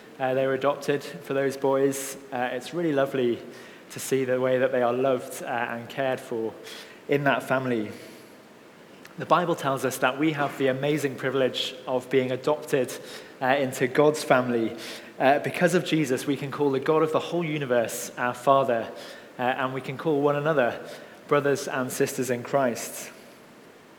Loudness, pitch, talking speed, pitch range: -26 LUFS, 135 Hz, 175 wpm, 125-145 Hz